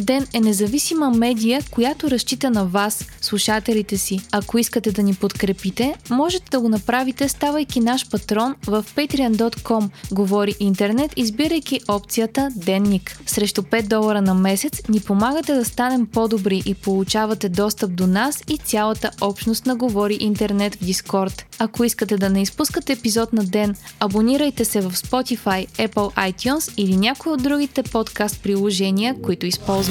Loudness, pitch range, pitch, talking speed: -20 LUFS, 200-255 Hz, 220 Hz, 145 wpm